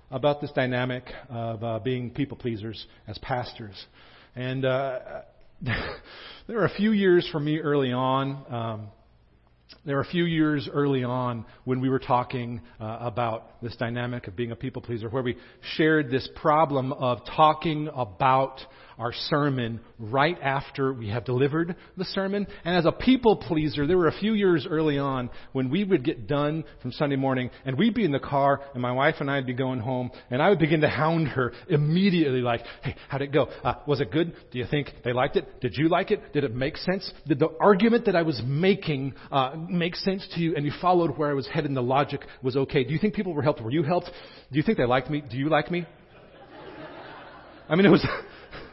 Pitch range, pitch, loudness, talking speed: 125-160 Hz, 140 Hz, -26 LUFS, 210 wpm